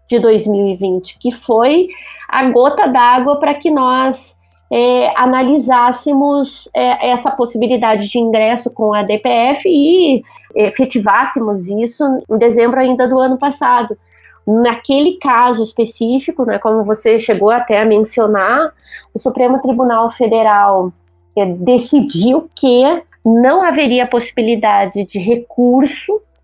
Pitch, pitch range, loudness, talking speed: 245 Hz, 220-265 Hz, -12 LUFS, 120 wpm